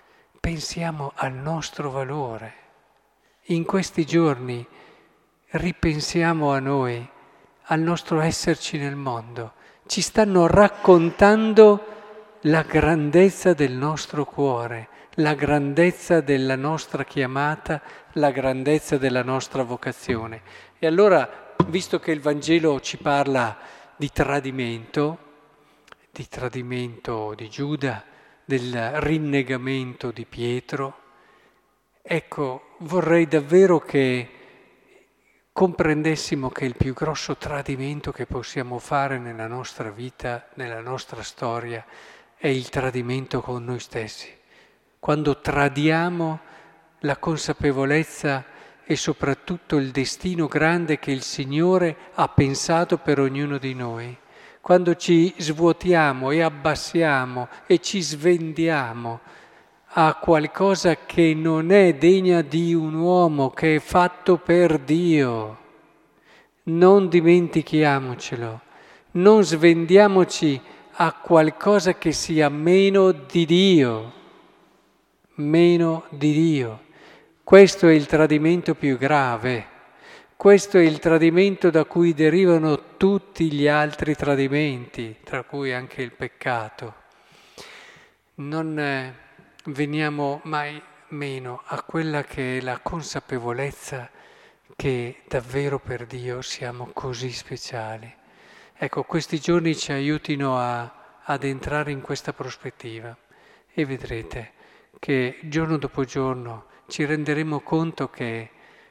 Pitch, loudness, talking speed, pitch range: 150 Hz, -21 LUFS, 105 wpm, 130-165 Hz